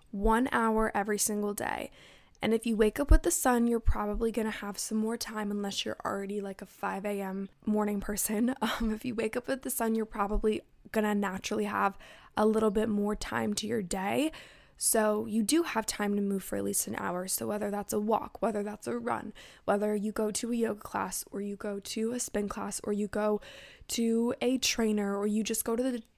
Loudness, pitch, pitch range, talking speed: -31 LUFS, 215 Hz, 205-230 Hz, 220 wpm